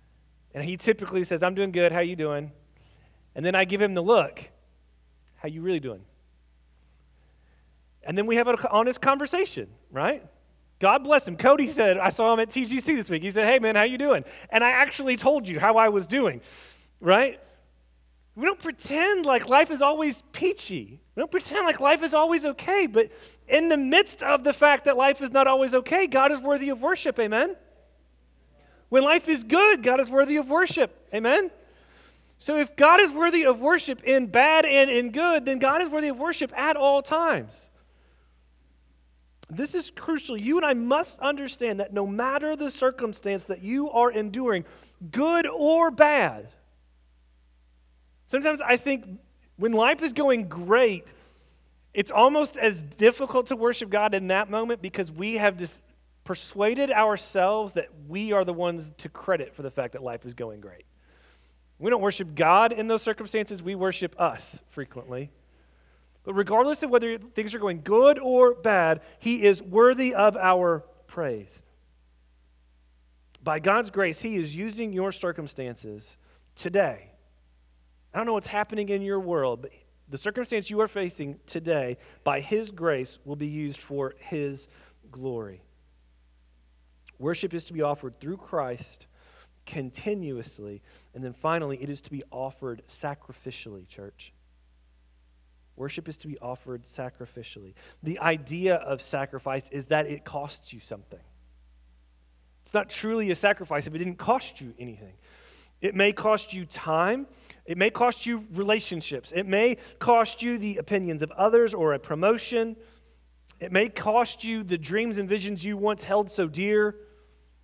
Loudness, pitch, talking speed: -24 LUFS, 195 Hz, 165 wpm